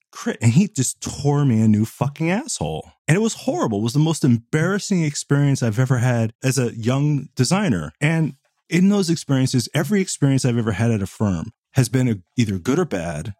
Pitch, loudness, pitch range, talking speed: 130 Hz, -20 LUFS, 115-160 Hz, 205 wpm